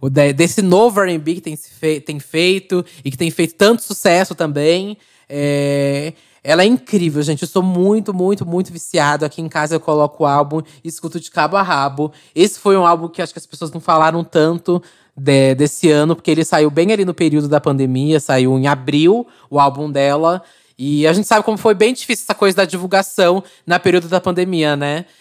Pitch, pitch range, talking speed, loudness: 165 Hz, 150-185 Hz, 205 wpm, -15 LUFS